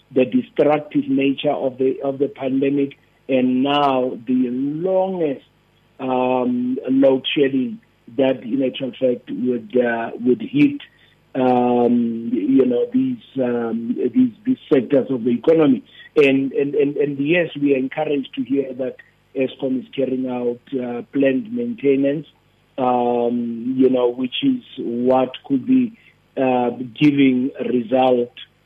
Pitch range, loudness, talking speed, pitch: 125-145 Hz, -19 LUFS, 135 wpm, 130 Hz